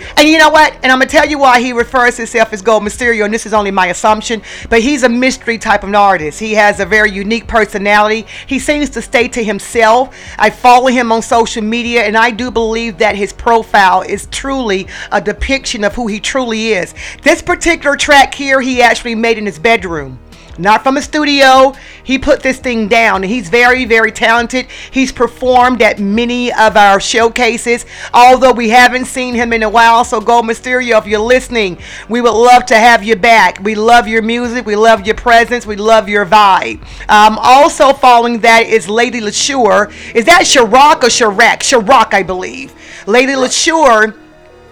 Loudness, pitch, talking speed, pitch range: -9 LUFS, 230 Hz, 195 wpm, 215-250 Hz